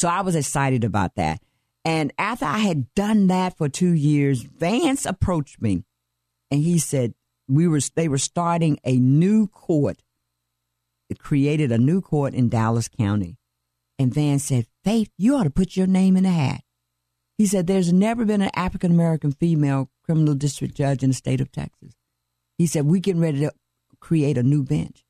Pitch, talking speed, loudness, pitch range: 145 Hz, 185 wpm, -21 LUFS, 120-175 Hz